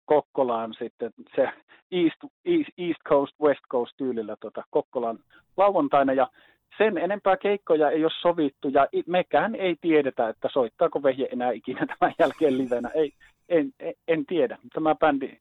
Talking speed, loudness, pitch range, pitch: 150 wpm, -25 LUFS, 130-180 Hz, 150 Hz